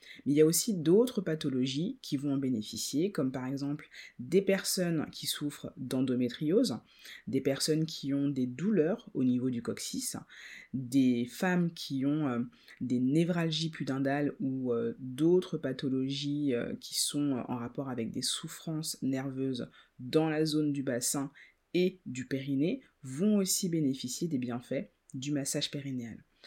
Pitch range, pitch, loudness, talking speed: 130-160 Hz, 140 Hz, -32 LUFS, 145 wpm